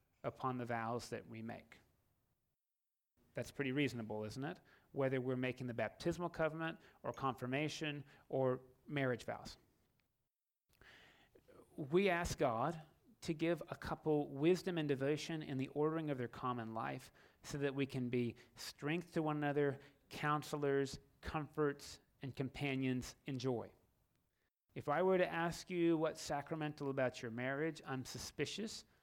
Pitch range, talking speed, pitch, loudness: 125-155 Hz, 140 wpm, 140 Hz, -41 LUFS